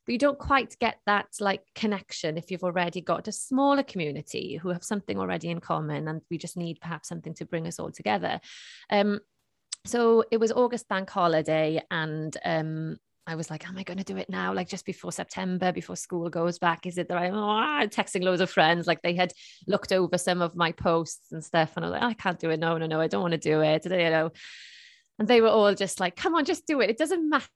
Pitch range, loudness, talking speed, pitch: 165-210 Hz, -27 LUFS, 245 wpm, 180 Hz